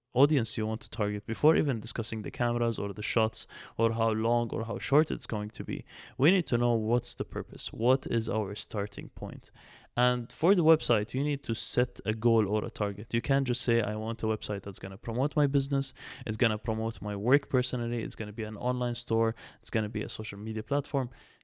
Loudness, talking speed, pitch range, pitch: -30 LUFS, 235 wpm, 110-130 Hz, 115 Hz